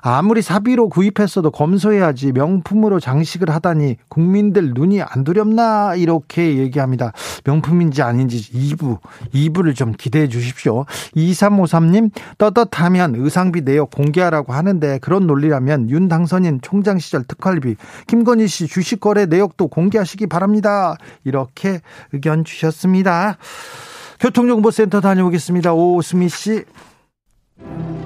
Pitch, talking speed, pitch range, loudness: 175 Hz, 305 characters per minute, 150-205 Hz, -16 LUFS